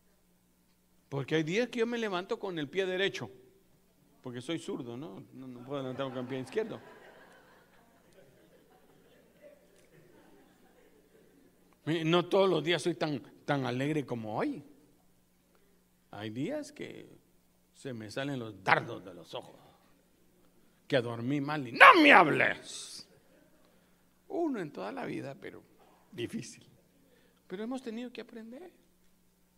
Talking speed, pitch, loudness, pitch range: 130 wpm, 150 Hz, -29 LUFS, 125-195 Hz